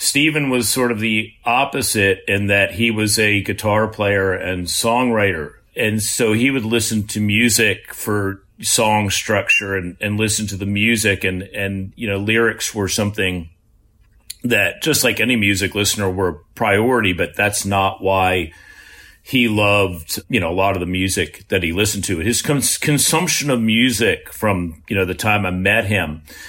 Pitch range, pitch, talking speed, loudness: 95-110 Hz, 105 Hz, 170 wpm, -17 LUFS